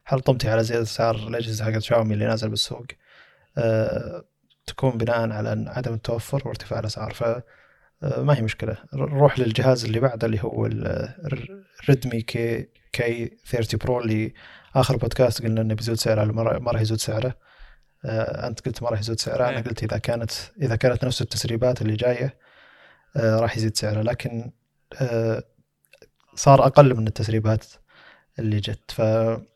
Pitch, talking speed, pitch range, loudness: 115 Hz, 150 wpm, 110-125 Hz, -23 LUFS